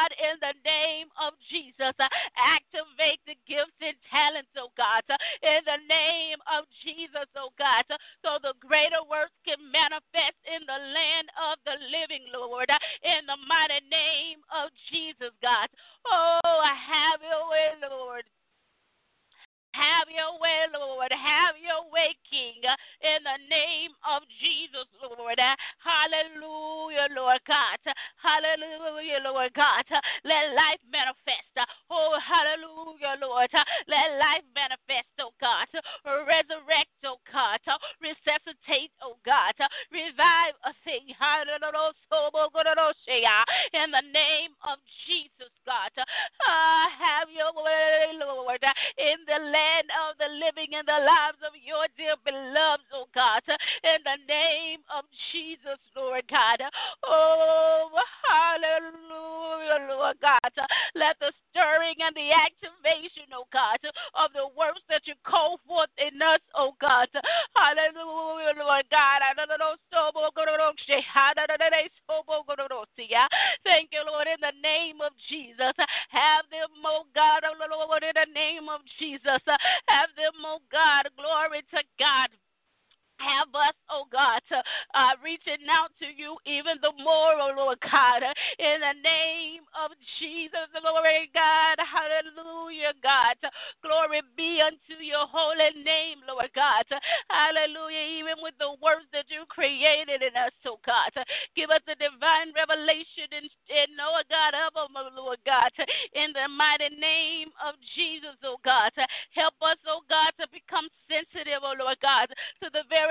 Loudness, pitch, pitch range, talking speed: -25 LUFS, 305 Hz, 280-320 Hz, 130 wpm